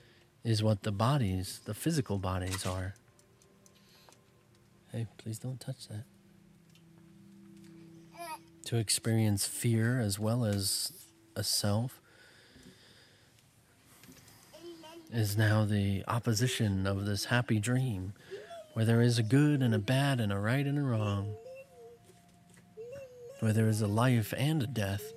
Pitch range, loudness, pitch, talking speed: 110-150 Hz, -31 LUFS, 120 Hz, 120 wpm